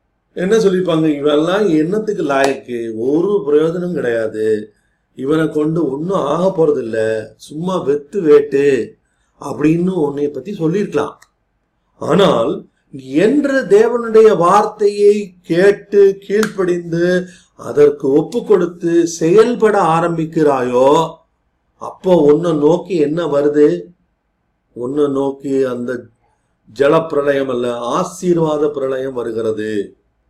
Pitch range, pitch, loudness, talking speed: 135-195 Hz, 160 Hz, -15 LUFS, 80 wpm